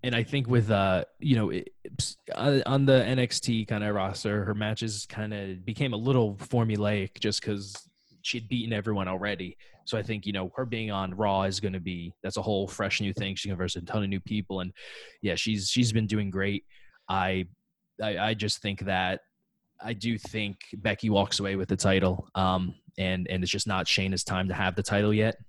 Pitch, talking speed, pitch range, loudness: 105 Hz, 210 wpm, 95-110 Hz, -29 LUFS